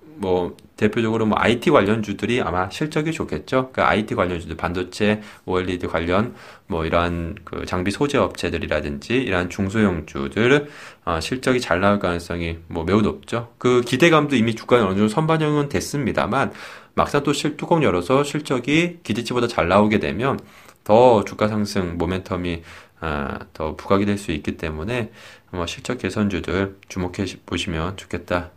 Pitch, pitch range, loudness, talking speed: 100 Hz, 90-125 Hz, -21 LUFS, 350 characters per minute